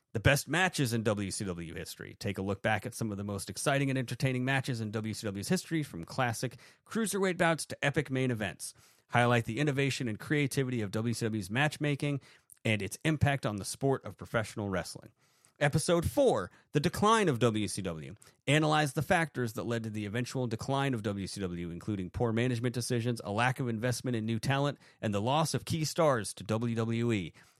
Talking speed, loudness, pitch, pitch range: 180 wpm, -32 LUFS, 120 Hz, 110-140 Hz